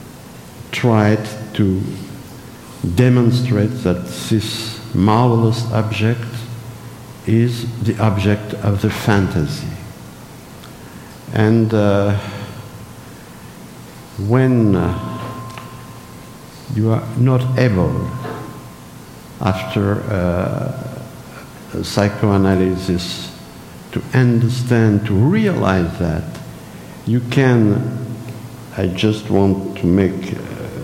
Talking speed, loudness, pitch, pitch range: 70 wpm, -17 LUFS, 110 Hz, 100-120 Hz